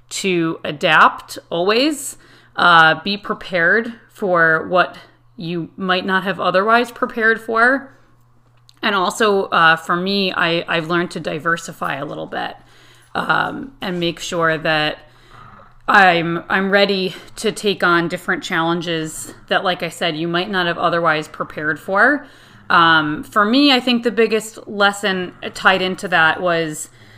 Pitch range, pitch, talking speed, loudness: 165-200 Hz, 180 Hz, 140 wpm, -17 LUFS